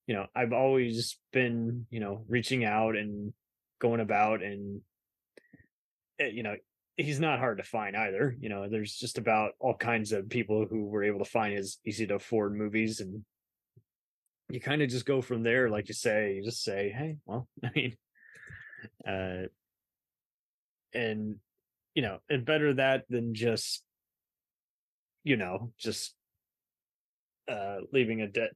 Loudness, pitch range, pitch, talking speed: -32 LUFS, 100-120 Hz, 110 Hz, 155 wpm